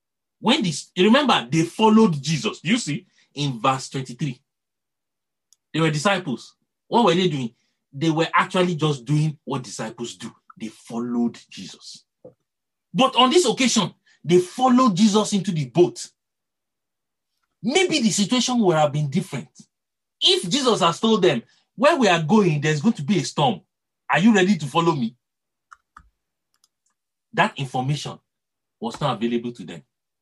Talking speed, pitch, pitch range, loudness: 150 wpm, 170 Hz, 140-215 Hz, -20 LUFS